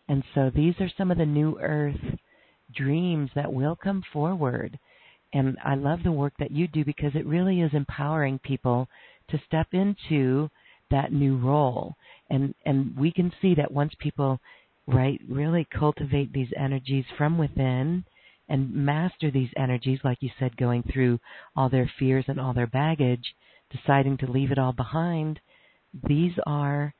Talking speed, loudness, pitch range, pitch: 160 wpm, -26 LUFS, 130-155 Hz, 145 Hz